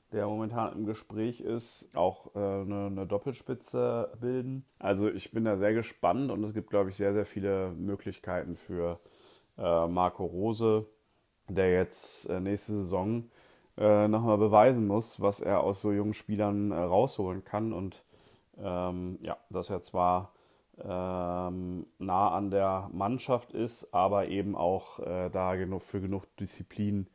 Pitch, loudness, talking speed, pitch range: 100 Hz, -31 LUFS, 155 wpm, 95-110 Hz